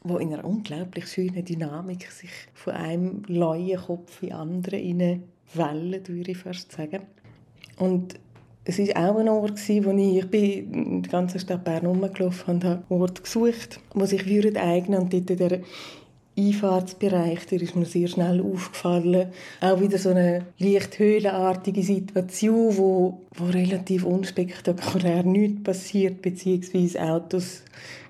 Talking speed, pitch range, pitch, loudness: 145 wpm, 175-190 Hz, 185 Hz, -25 LUFS